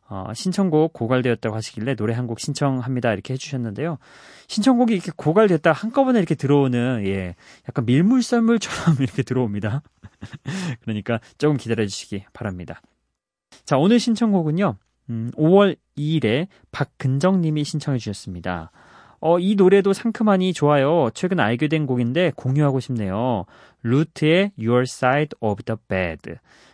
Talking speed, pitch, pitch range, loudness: 355 characters per minute, 135 Hz, 115-170 Hz, -21 LUFS